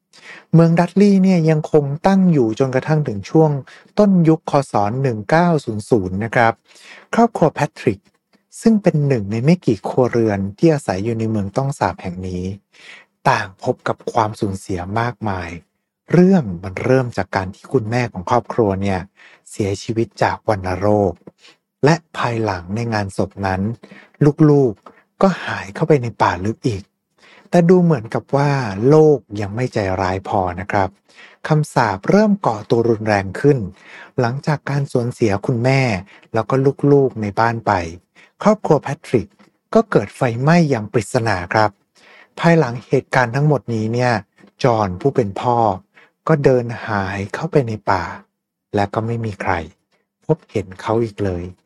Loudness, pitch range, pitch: -18 LUFS, 105-150 Hz, 120 Hz